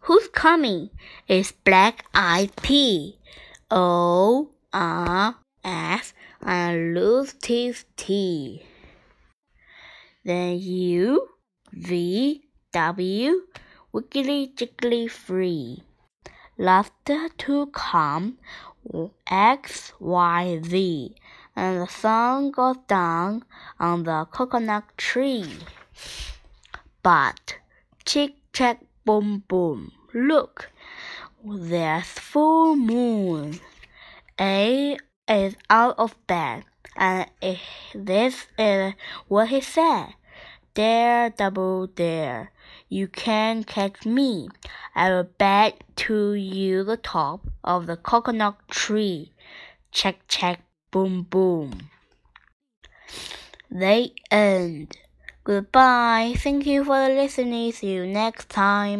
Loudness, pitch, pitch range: -22 LUFS, 205 Hz, 185-250 Hz